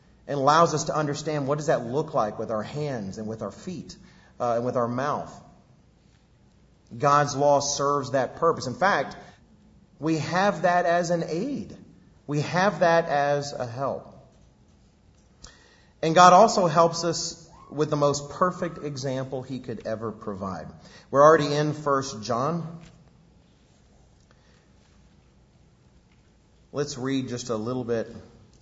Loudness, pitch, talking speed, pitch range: -24 LUFS, 145 Hz, 135 wpm, 125-165 Hz